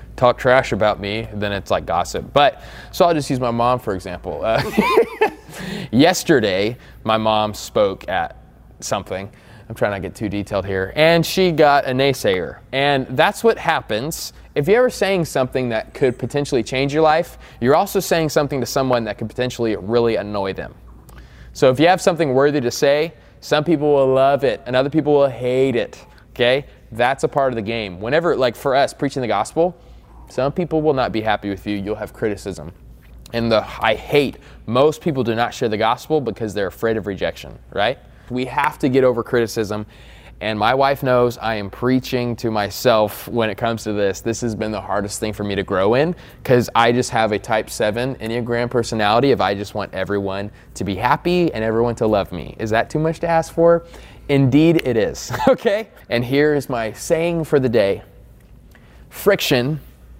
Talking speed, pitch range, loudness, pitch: 195 wpm, 105-145 Hz, -19 LUFS, 120 Hz